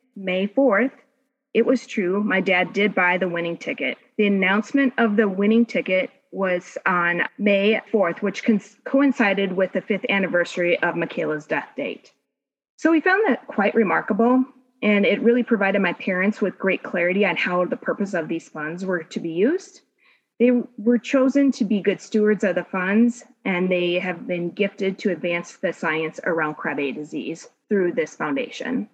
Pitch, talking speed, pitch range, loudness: 205 Hz, 170 wpm, 180-240 Hz, -22 LUFS